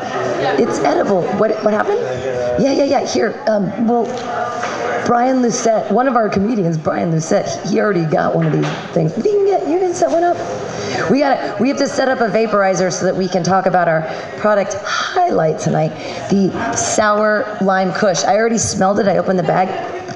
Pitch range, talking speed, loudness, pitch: 190-245 Hz, 195 wpm, -16 LUFS, 215 Hz